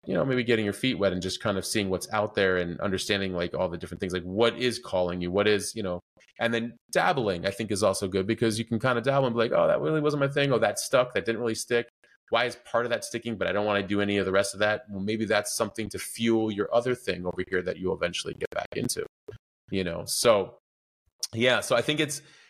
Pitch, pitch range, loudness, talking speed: 105 Hz, 95-115 Hz, -27 LUFS, 275 wpm